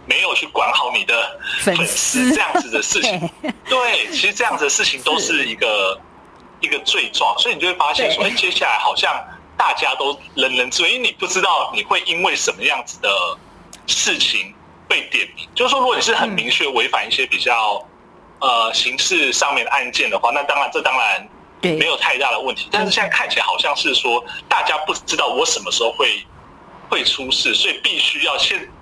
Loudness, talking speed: -16 LUFS, 295 characters per minute